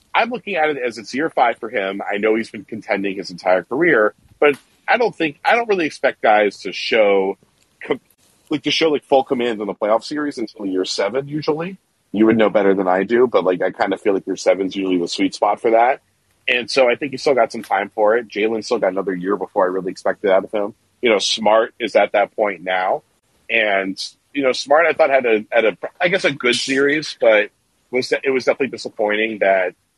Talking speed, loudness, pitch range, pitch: 235 wpm, -18 LUFS, 95-140 Hz, 110 Hz